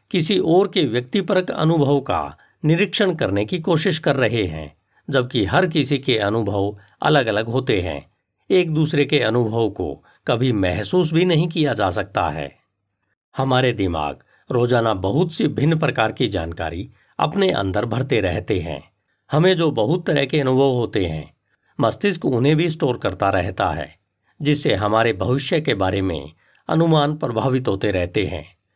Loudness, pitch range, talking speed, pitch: -20 LUFS, 100-160 Hz, 155 wpm, 130 Hz